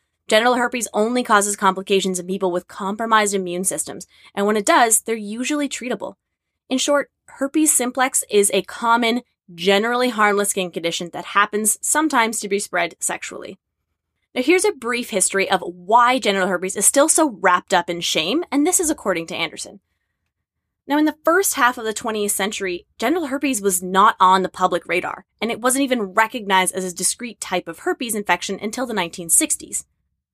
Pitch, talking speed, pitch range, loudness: 210 Hz, 180 wpm, 190-250 Hz, -19 LUFS